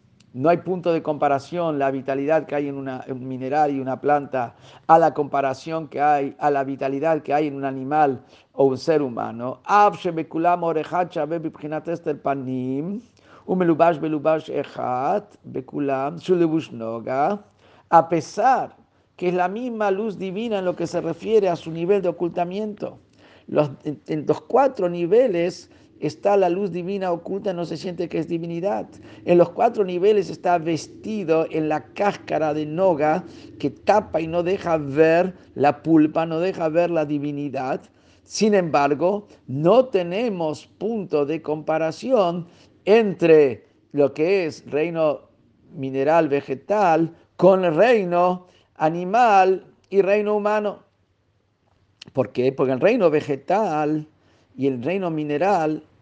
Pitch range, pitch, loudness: 140-180 Hz, 160 Hz, -21 LUFS